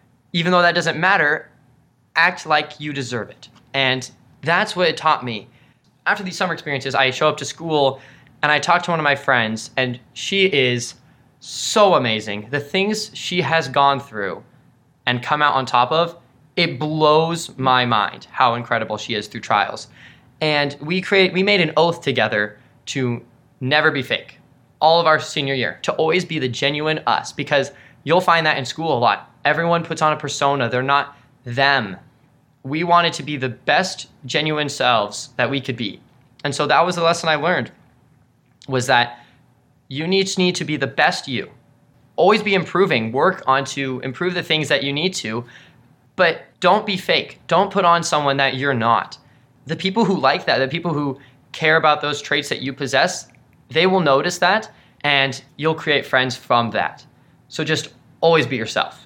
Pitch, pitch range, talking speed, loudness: 145 Hz, 130-165 Hz, 185 wpm, -19 LUFS